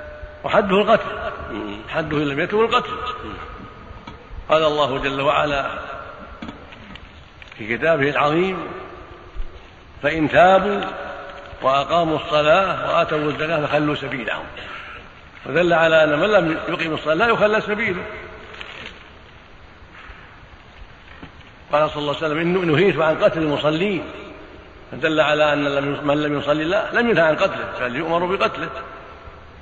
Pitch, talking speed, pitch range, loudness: 155 Hz, 110 wpm, 140-170 Hz, -19 LUFS